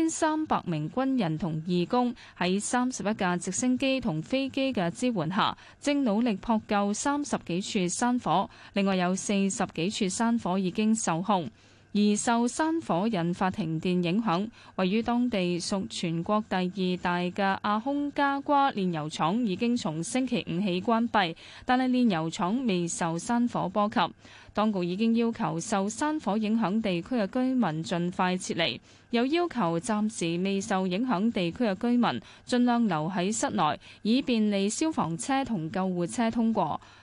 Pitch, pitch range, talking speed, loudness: 205 Hz, 180-240 Hz, 240 characters per minute, -28 LUFS